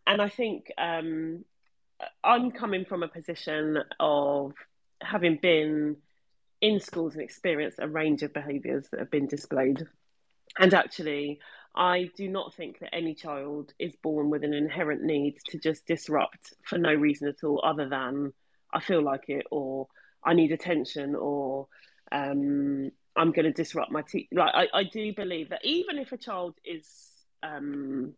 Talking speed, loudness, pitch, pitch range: 165 wpm, -29 LUFS, 155 Hz, 145-175 Hz